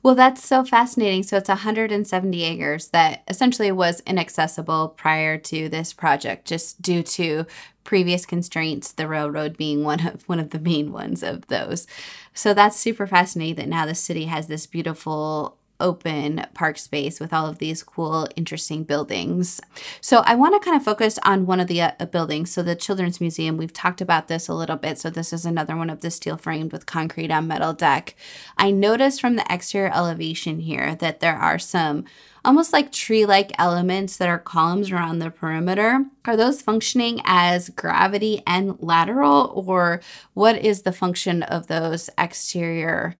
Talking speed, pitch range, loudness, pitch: 180 wpm, 160-200 Hz, -21 LUFS, 170 Hz